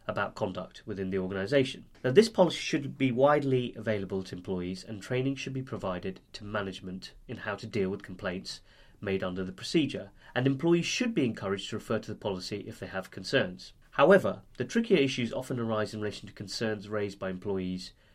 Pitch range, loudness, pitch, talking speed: 95-135 Hz, -31 LUFS, 110 Hz, 190 wpm